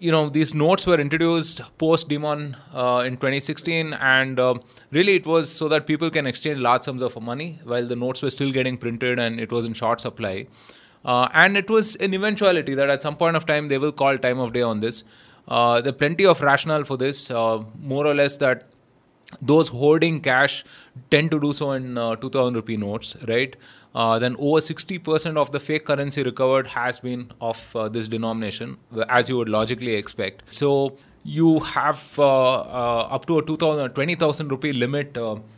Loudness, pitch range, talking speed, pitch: -21 LUFS, 120-155 Hz, 195 wpm, 135 Hz